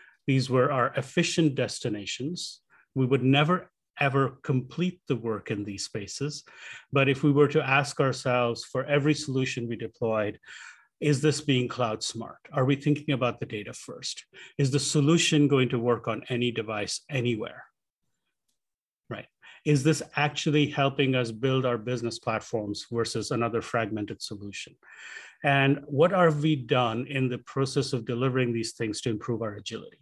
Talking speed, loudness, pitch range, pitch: 160 wpm, -27 LUFS, 115-145 Hz, 130 Hz